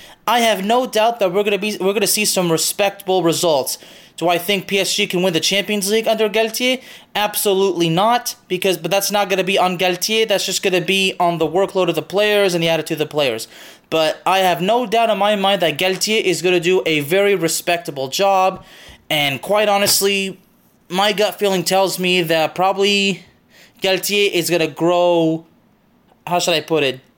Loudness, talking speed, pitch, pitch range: -17 LUFS, 205 wpm, 190 Hz, 175-205 Hz